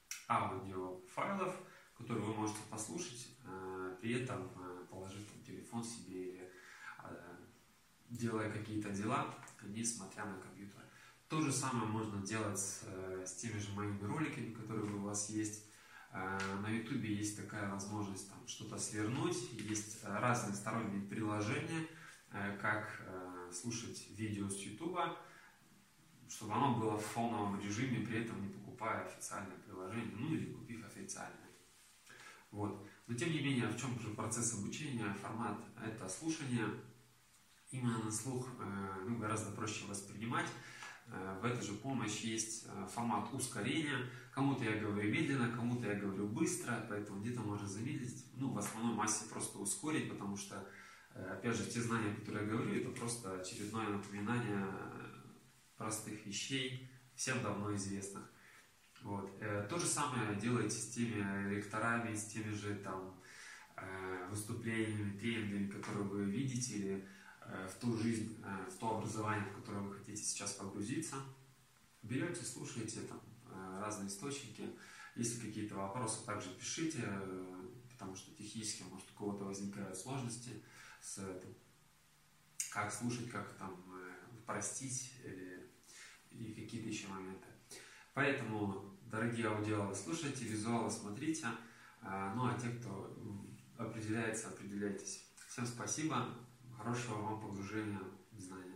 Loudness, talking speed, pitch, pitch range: -42 LUFS, 125 wpm, 110 Hz, 100-120 Hz